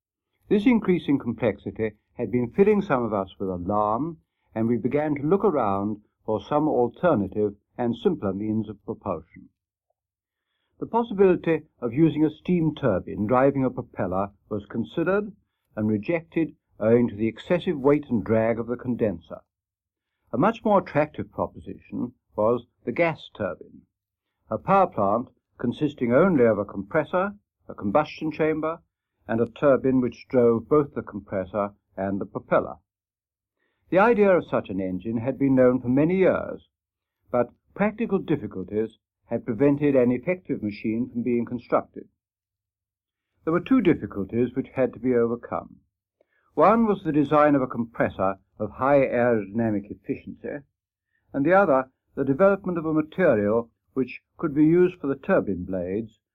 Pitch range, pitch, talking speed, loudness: 105-150 Hz, 120 Hz, 150 wpm, -24 LUFS